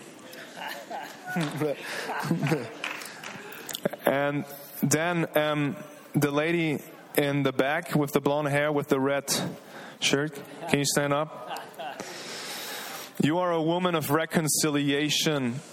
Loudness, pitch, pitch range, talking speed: -27 LUFS, 150 Hz, 145-160 Hz, 100 wpm